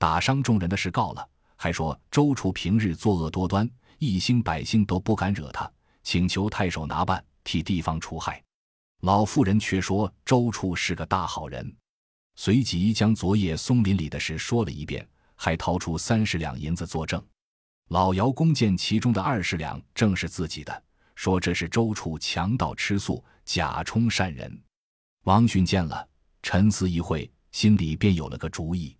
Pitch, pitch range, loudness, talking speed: 95 Hz, 85-110 Hz, -25 LUFS, 245 characters per minute